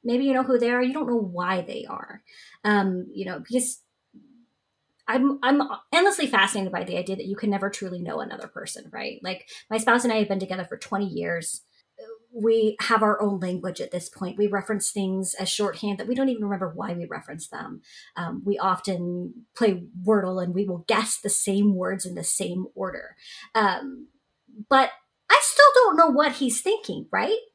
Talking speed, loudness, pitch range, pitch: 200 wpm, -24 LUFS, 190-255 Hz, 210 Hz